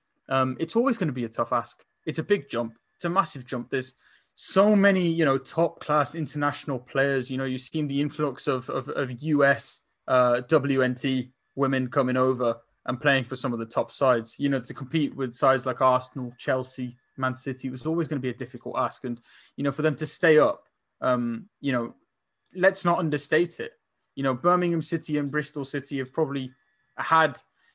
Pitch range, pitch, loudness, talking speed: 130-155 Hz, 135 Hz, -26 LUFS, 205 wpm